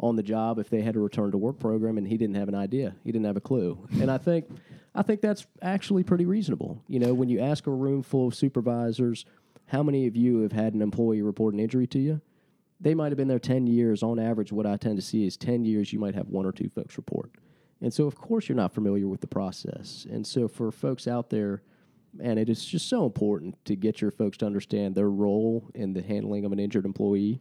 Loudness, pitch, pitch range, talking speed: -28 LUFS, 115 Hz, 105-135 Hz, 255 wpm